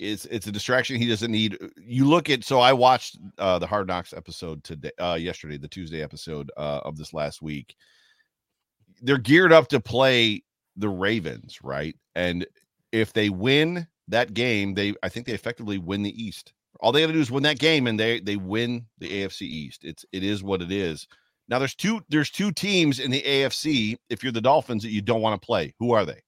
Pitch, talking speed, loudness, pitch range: 110 Hz, 215 wpm, -23 LUFS, 95-130 Hz